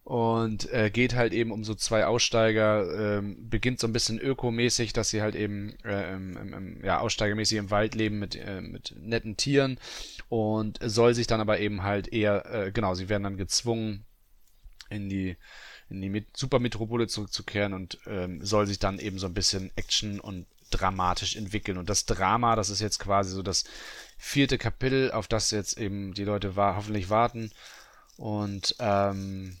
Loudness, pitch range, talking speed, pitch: -28 LUFS, 100-115 Hz, 175 wpm, 105 Hz